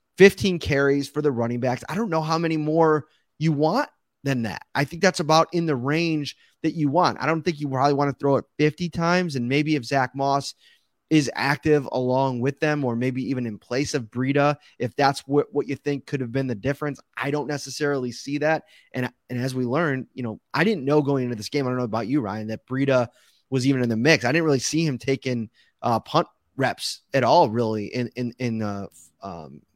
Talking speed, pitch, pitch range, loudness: 230 wpm, 140 Hz, 125-150 Hz, -23 LUFS